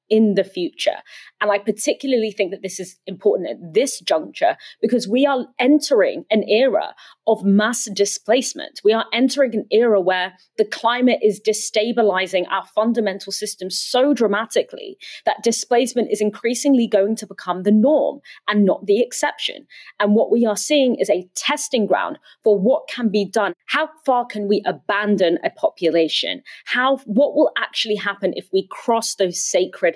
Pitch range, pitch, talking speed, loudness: 205-275 Hz, 220 Hz, 165 wpm, -19 LUFS